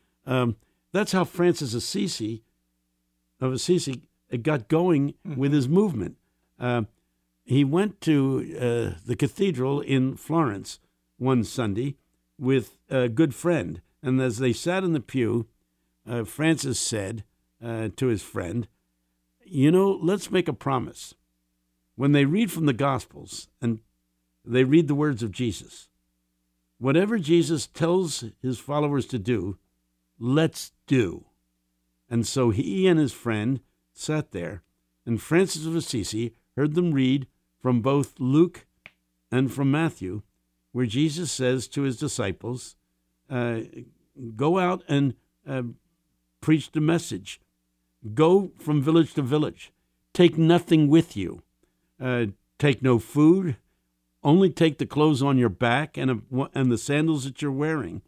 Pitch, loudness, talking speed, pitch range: 125 Hz, -25 LUFS, 135 wpm, 95-150 Hz